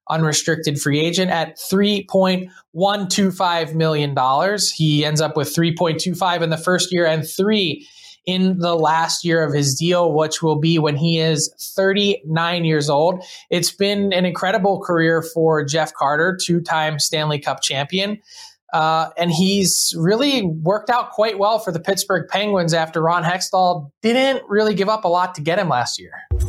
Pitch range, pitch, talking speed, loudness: 160-195 Hz, 175 Hz, 180 wpm, -18 LUFS